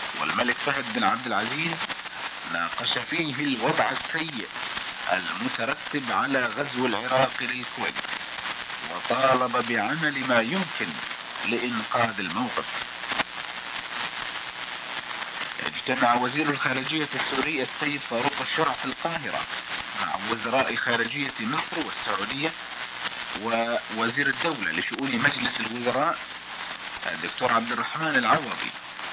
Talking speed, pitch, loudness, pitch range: 90 wpm, 130 Hz, -26 LUFS, 125-145 Hz